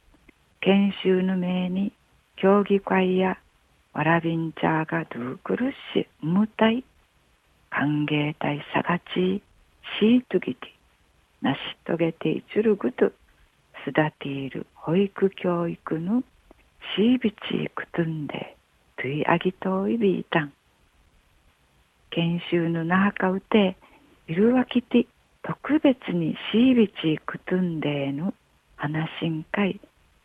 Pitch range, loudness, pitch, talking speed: 150-200 Hz, -25 LUFS, 175 Hz, 235 characters per minute